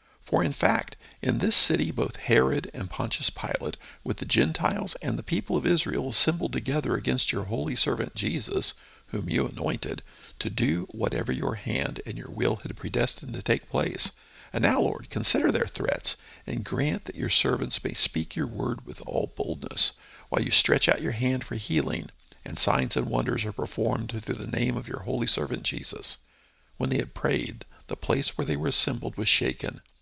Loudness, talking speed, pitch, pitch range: -28 LUFS, 190 wpm, 115 Hz, 95-125 Hz